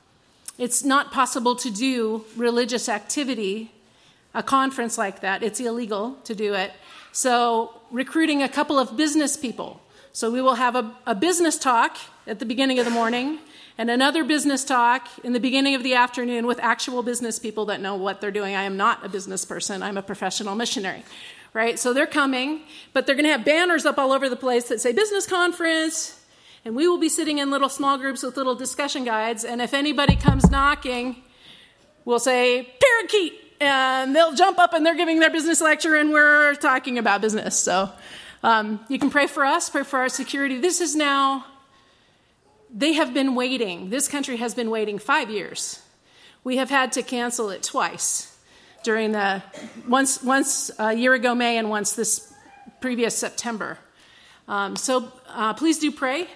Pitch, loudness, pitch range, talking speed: 255 Hz, -22 LUFS, 230-285 Hz, 185 wpm